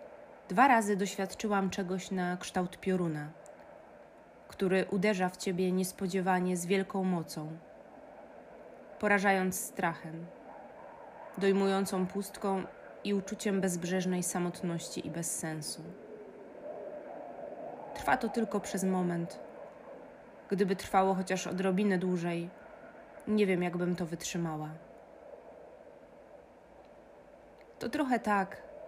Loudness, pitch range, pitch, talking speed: -32 LUFS, 180-205 Hz, 190 Hz, 90 wpm